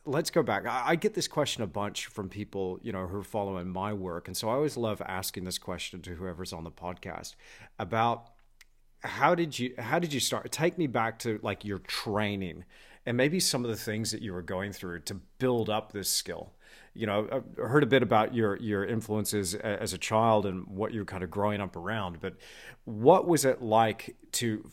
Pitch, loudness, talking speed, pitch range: 110 Hz, -30 LUFS, 215 wpm, 95-120 Hz